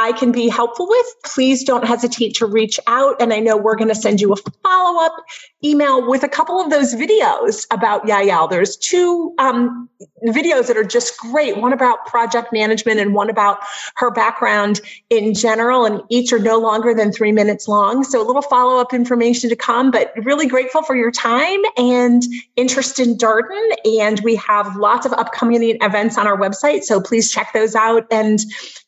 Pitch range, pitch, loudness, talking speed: 220-265 Hz, 235 Hz, -15 LUFS, 185 wpm